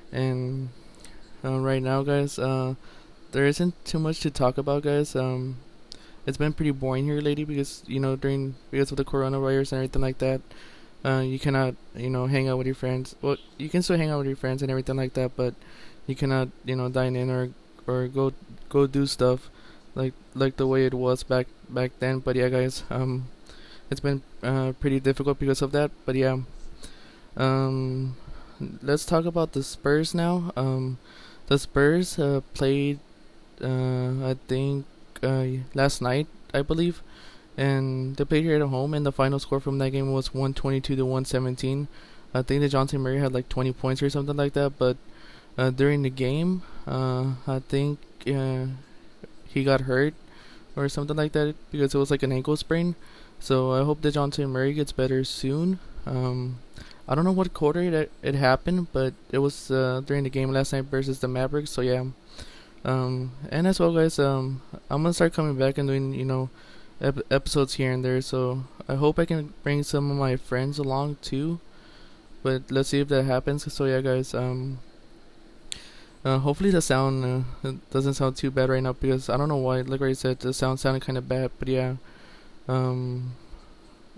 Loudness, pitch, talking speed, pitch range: -26 LUFS, 135 Hz, 190 wpm, 130-140 Hz